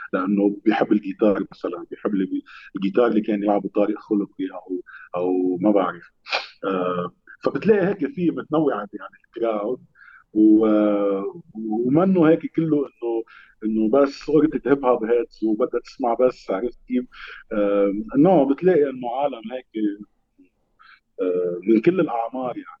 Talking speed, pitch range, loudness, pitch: 125 wpm, 100-130 Hz, -22 LUFS, 110 Hz